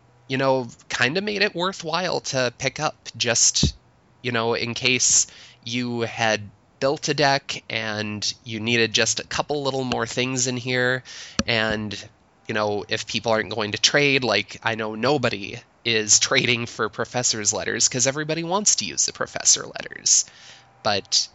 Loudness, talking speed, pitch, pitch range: -21 LUFS, 165 wpm, 120 Hz, 110-135 Hz